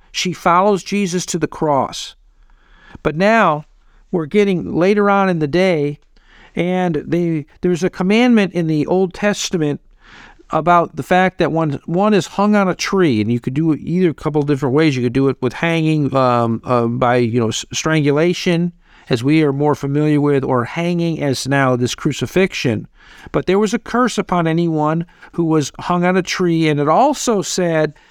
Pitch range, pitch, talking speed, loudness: 145-185 Hz, 165 Hz, 185 wpm, -16 LUFS